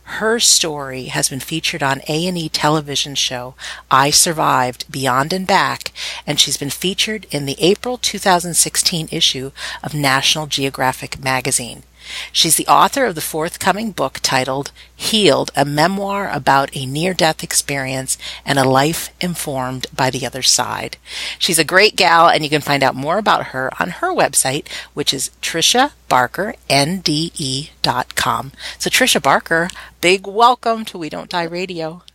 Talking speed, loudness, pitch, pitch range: 155 wpm, -16 LUFS, 155 Hz, 135-180 Hz